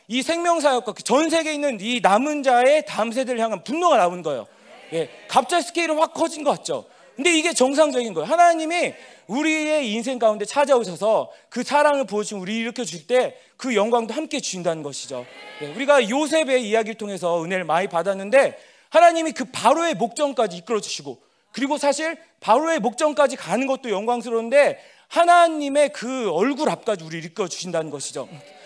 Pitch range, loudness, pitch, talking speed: 210-300 Hz, -21 LUFS, 255 Hz, 395 characters per minute